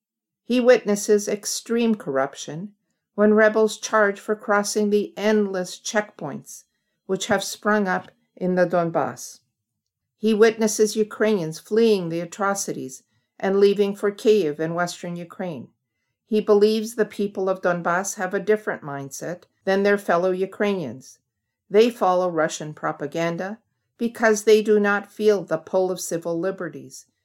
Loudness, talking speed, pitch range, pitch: -22 LUFS, 130 wpm, 170-215 Hz, 200 Hz